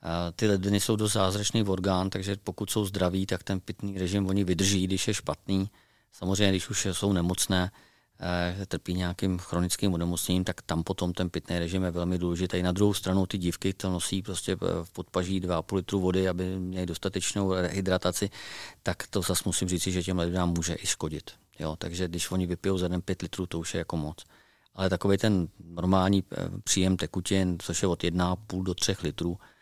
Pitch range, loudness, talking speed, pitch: 90-95 Hz, -29 LUFS, 190 wpm, 95 Hz